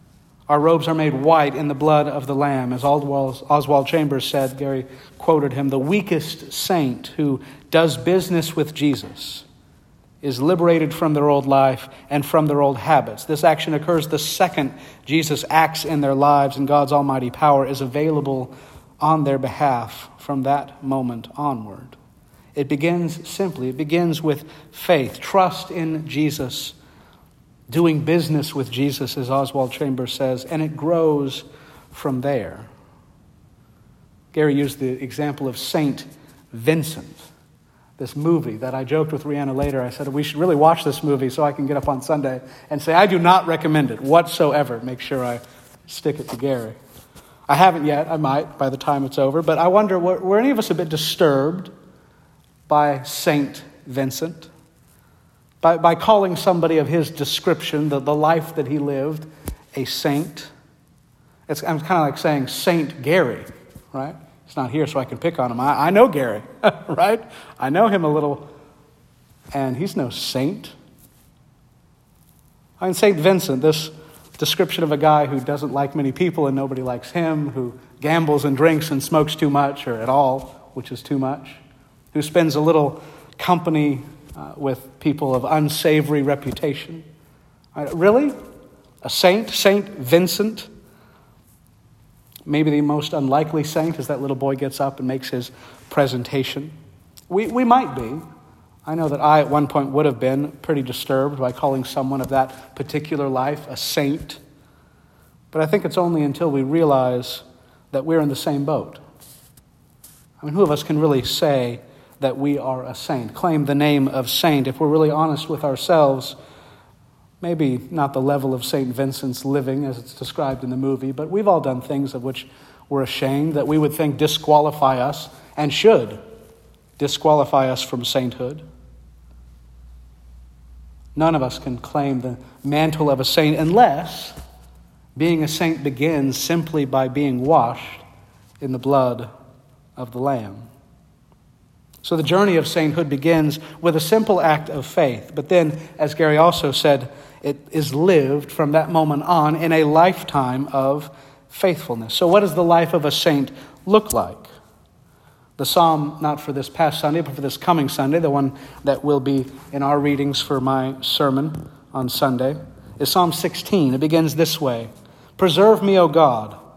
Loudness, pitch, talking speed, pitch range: -19 LUFS, 145 Hz, 165 wpm, 135-160 Hz